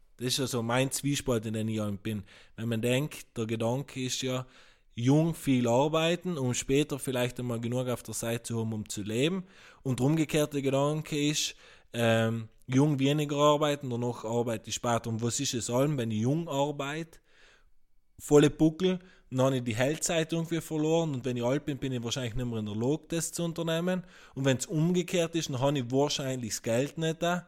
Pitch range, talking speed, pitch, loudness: 120-150 Hz, 205 wpm, 130 Hz, -30 LUFS